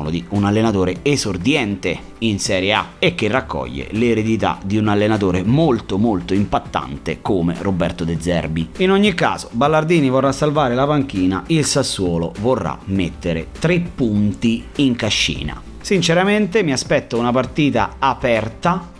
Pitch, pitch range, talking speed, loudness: 110 Hz, 90-140 Hz, 135 wpm, -18 LUFS